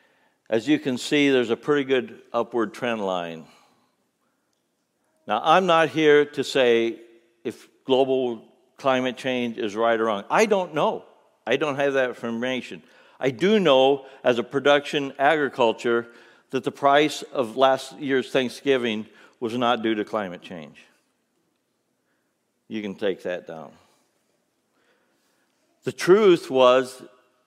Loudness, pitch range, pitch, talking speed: -22 LUFS, 115-145 Hz, 130 Hz, 135 wpm